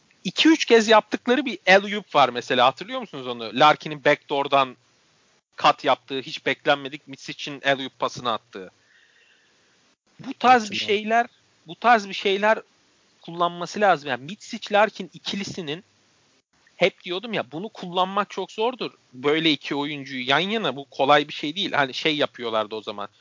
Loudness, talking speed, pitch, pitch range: -22 LUFS, 155 wpm, 175 Hz, 140-210 Hz